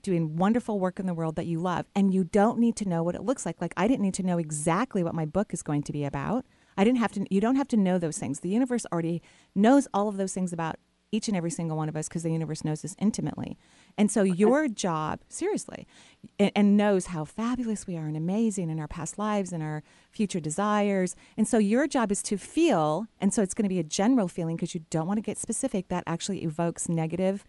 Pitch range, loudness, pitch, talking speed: 165-215 Hz, -27 LUFS, 190 Hz, 255 wpm